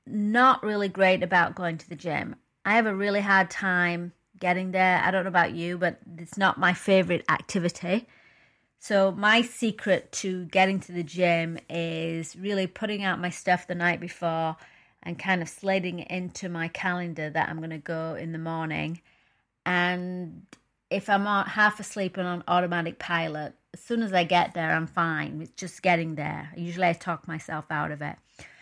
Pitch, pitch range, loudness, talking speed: 180 Hz, 165-190 Hz, -26 LUFS, 185 wpm